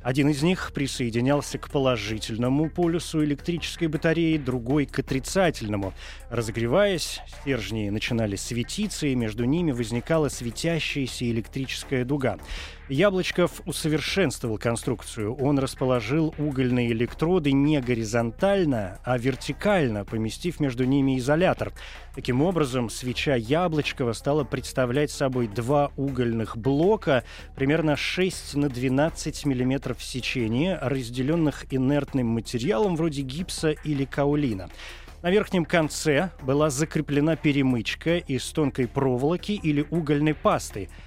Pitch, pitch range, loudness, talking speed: 140 Hz, 120-155 Hz, -25 LUFS, 105 wpm